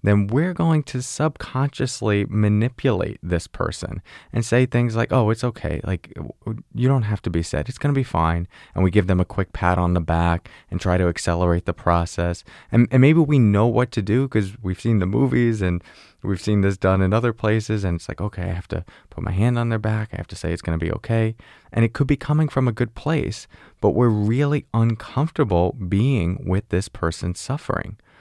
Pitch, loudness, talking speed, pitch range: 105 Hz, -21 LUFS, 220 wpm, 90-125 Hz